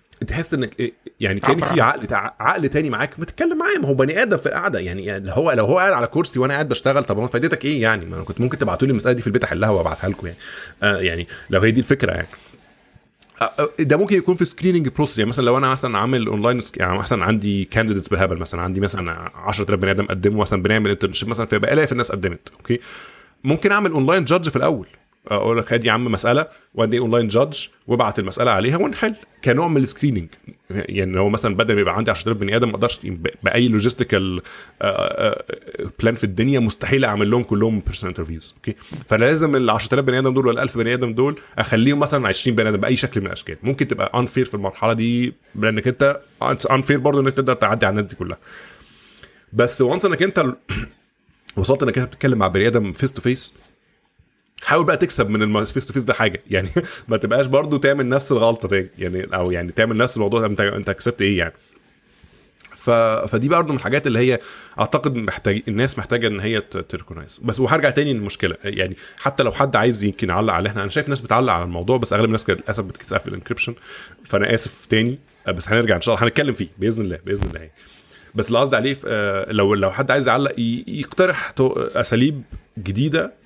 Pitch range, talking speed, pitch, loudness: 100-135 Hz, 205 wpm, 115 Hz, -19 LUFS